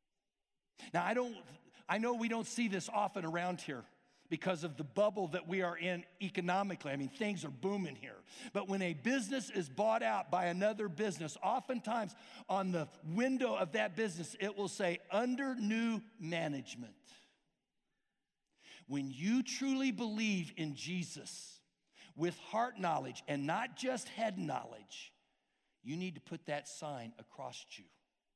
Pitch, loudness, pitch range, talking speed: 190 Hz, -38 LUFS, 165-225 Hz, 150 wpm